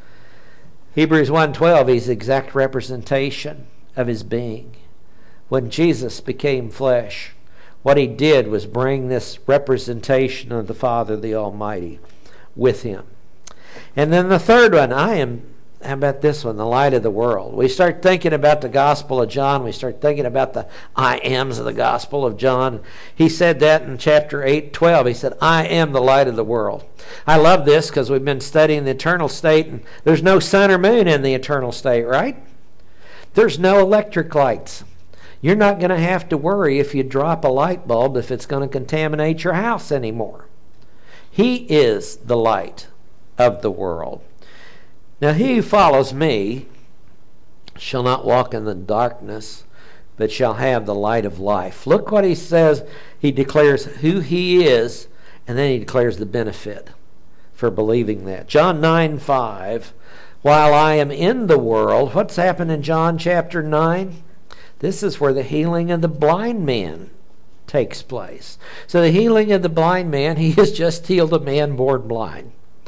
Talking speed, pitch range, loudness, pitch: 175 wpm, 120-165 Hz, -17 LUFS, 140 Hz